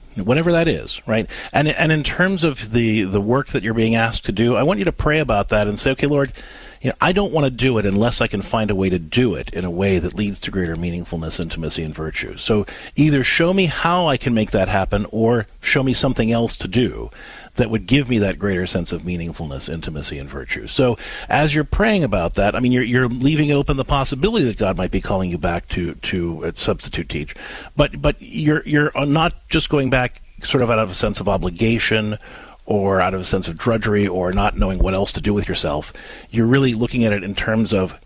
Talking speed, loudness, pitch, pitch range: 245 wpm, -19 LUFS, 110 Hz, 95-135 Hz